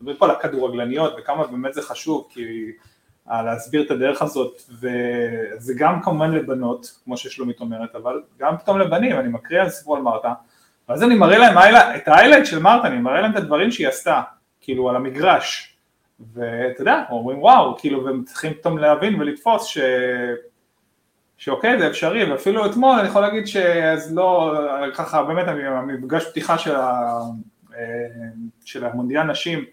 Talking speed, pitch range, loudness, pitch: 155 wpm, 120-165 Hz, -18 LUFS, 135 Hz